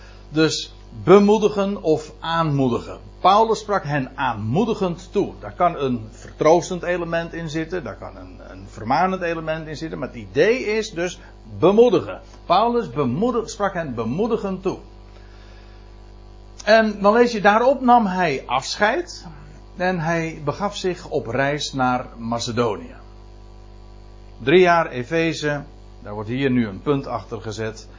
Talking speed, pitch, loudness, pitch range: 135 wpm, 145 Hz, -20 LUFS, 110-185 Hz